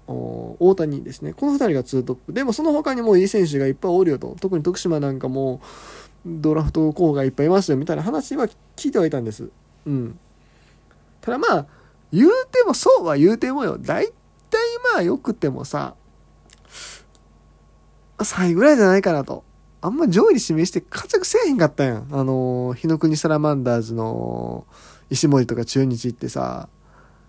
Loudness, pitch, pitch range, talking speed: -20 LUFS, 145 Hz, 115-195 Hz, 345 characters per minute